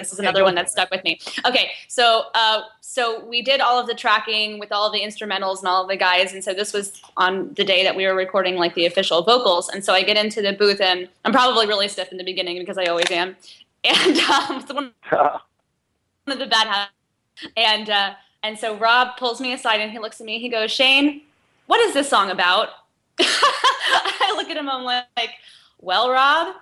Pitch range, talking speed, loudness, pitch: 190-240 Hz, 225 wpm, -19 LUFS, 210 Hz